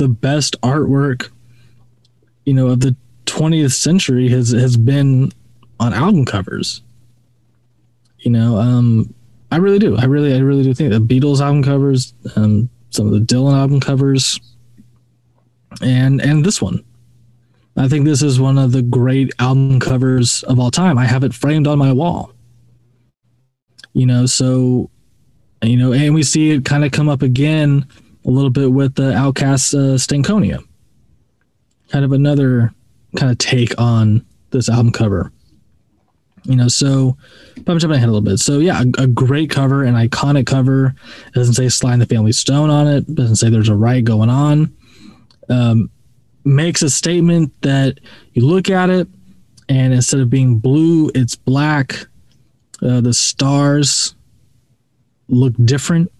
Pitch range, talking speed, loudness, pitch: 120-140 Hz, 160 wpm, -14 LUFS, 130 Hz